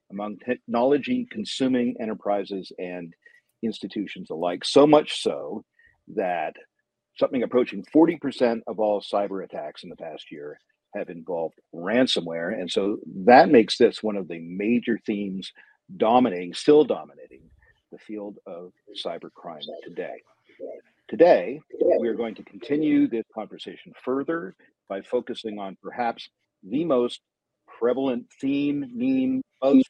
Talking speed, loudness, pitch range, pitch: 125 wpm, -24 LUFS, 100-150 Hz, 120 Hz